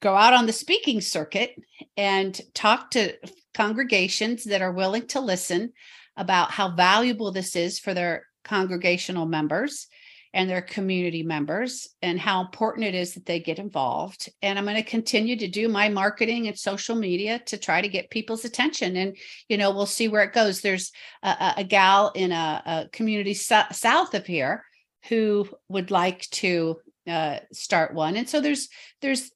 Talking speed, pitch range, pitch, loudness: 175 wpm, 185-225 Hz, 200 Hz, -24 LUFS